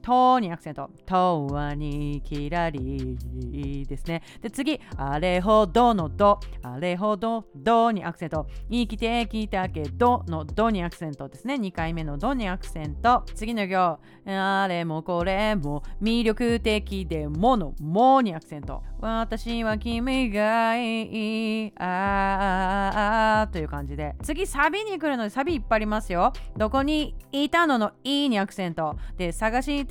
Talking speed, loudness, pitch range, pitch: 285 characters per minute, -25 LUFS, 165-230 Hz, 210 Hz